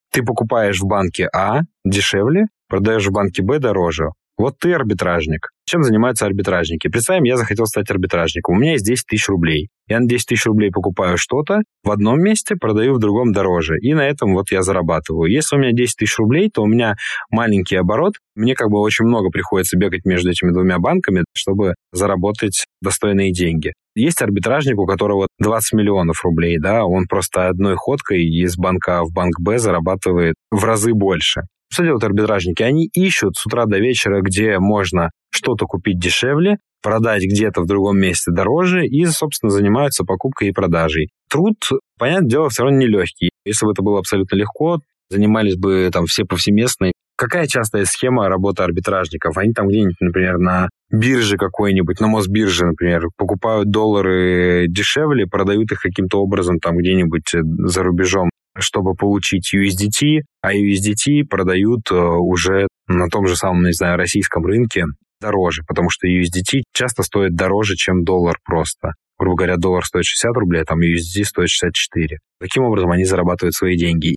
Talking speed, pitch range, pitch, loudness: 165 wpm, 90-110 Hz, 100 Hz, -16 LUFS